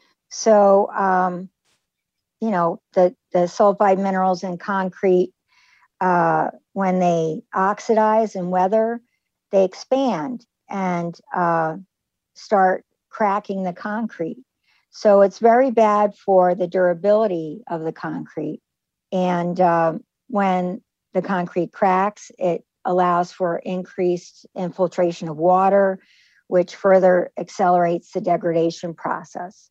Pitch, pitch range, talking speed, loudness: 185 Hz, 180-205 Hz, 105 wpm, -20 LUFS